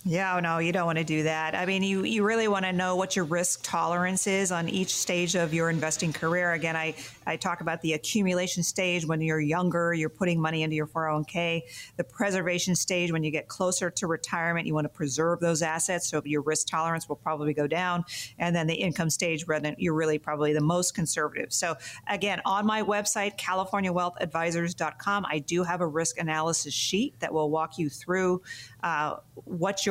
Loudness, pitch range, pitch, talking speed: -28 LUFS, 160-180 Hz, 170 Hz, 200 wpm